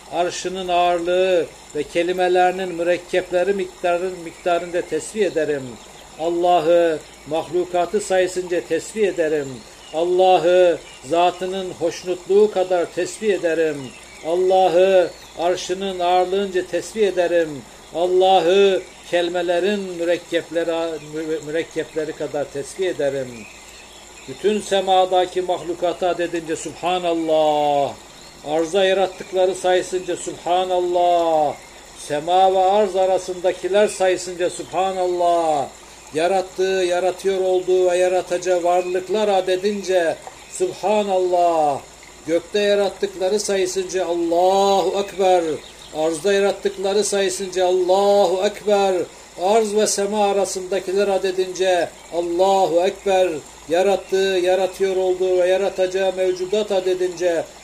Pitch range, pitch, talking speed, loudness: 170-190 Hz, 180 Hz, 80 wpm, -20 LUFS